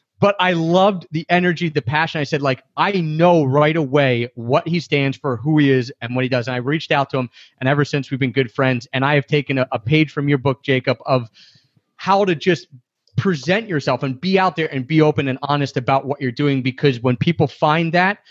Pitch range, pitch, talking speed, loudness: 130-165 Hz, 145 Hz, 240 wpm, -18 LUFS